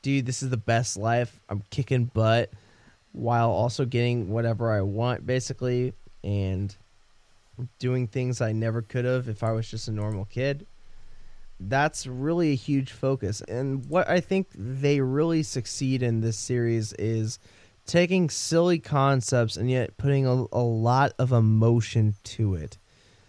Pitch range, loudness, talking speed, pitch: 110-130 Hz, -26 LUFS, 150 wpm, 120 Hz